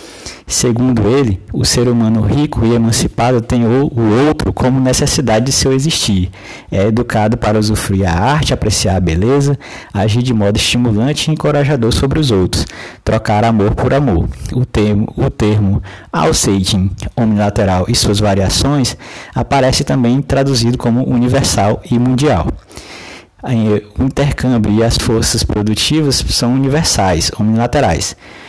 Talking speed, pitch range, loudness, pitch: 130 wpm, 105-130 Hz, -13 LUFS, 115 Hz